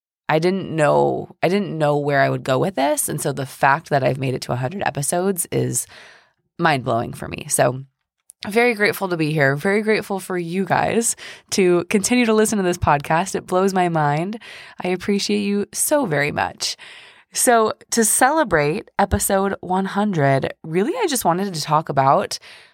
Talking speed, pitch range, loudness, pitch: 175 wpm, 145-205 Hz, -19 LUFS, 180 Hz